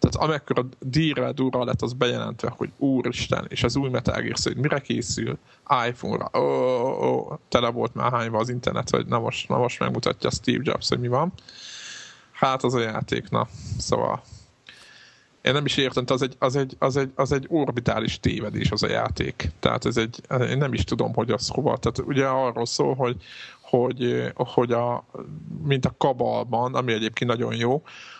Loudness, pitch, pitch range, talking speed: -24 LUFS, 130 Hz, 120-140 Hz, 185 wpm